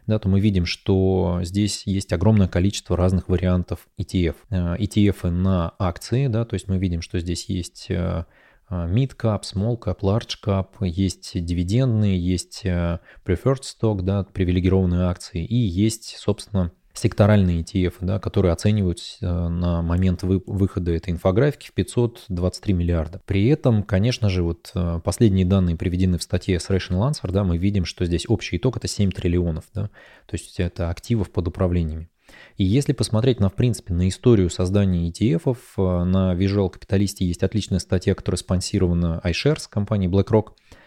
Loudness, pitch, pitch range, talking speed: -22 LUFS, 95 Hz, 90-105 Hz, 155 wpm